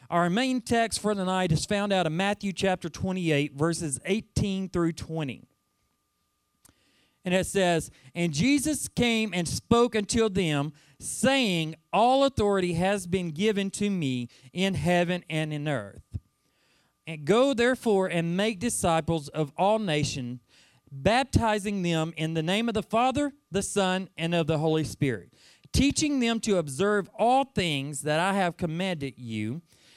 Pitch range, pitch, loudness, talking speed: 160-210 Hz, 185 Hz, -27 LUFS, 150 wpm